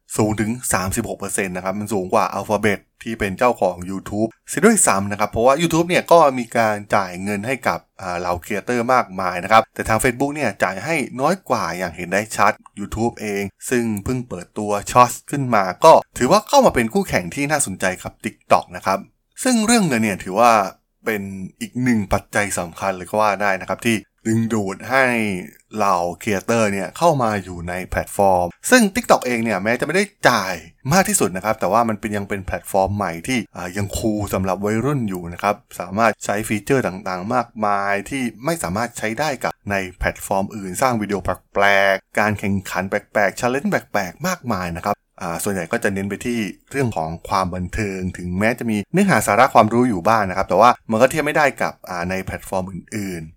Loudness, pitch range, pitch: -19 LUFS, 95-120 Hz, 105 Hz